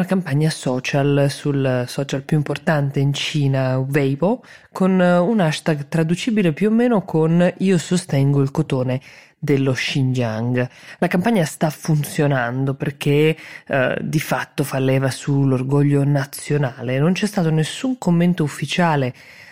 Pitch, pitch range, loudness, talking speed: 150 Hz, 135-170 Hz, -19 LUFS, 130 wpm